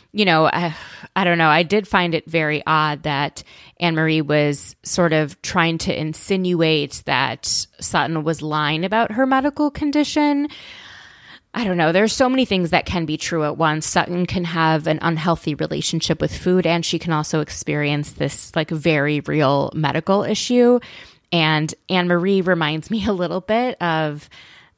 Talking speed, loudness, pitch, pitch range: 165 wpm, -19 LUFS, 165 Hz, 155-190 Hz